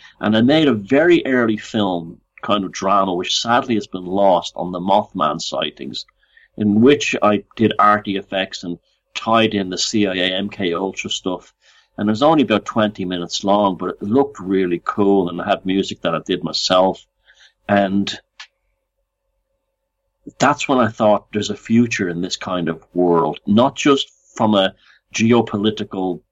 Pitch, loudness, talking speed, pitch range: 105 Hz, -18 LUFS, 165 wpm, 95-115 Hz